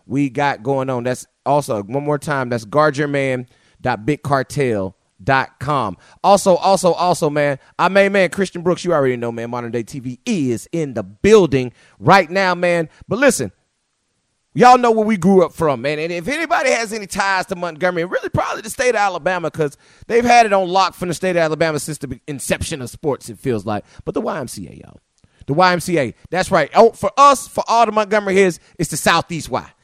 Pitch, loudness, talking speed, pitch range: 165 Hz, -17 LUFS, 195 wpm, 135-190 Hz